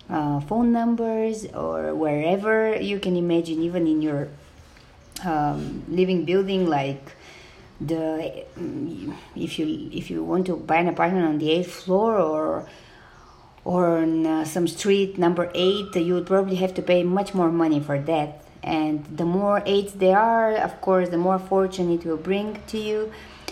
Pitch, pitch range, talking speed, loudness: 175 Hz, 160-195 Hz, 165 wpm, -23 LUFS